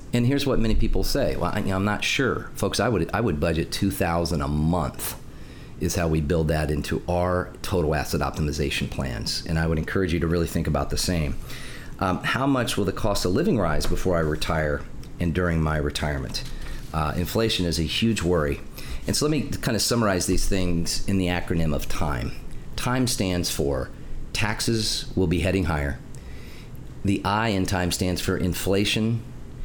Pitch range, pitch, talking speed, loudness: 80-100 Hz, 90 Hz, 190 wpm, -25 LUFS